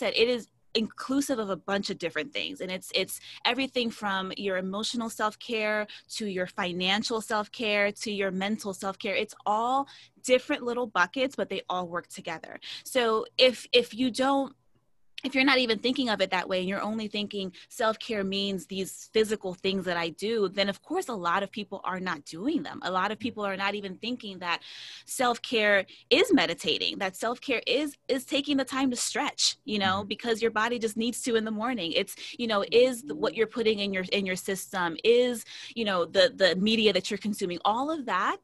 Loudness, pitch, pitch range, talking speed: -28 LUFS, 215 Hz, 195-245 Hz, 200 wpm